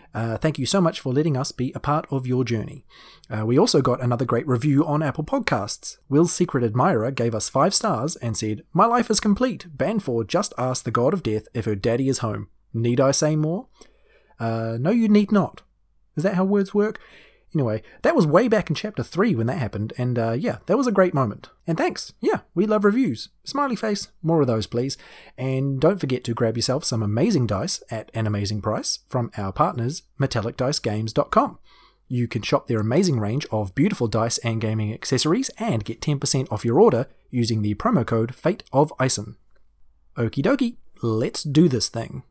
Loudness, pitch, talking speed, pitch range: -22 LUFS, 130 Hz, 200 wpm, 115-165 Hz